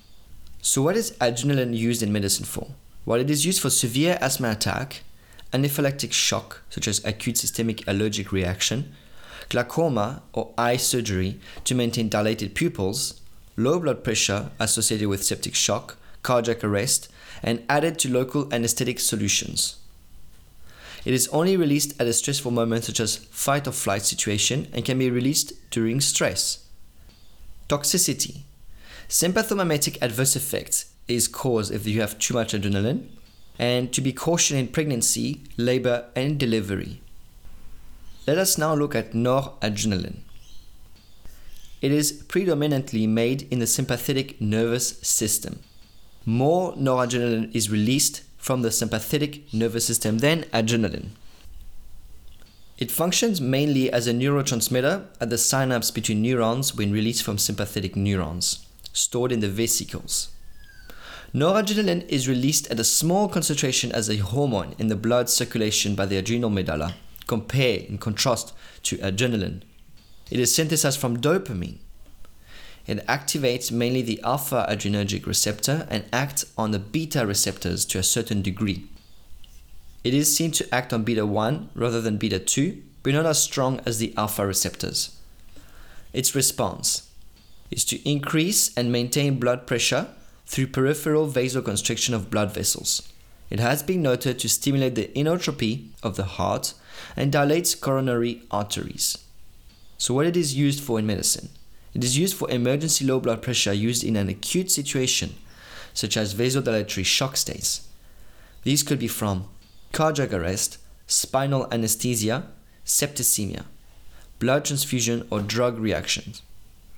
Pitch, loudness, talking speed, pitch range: 115 Hz, -23 LUFS, 140 wpm, 100-135 Hz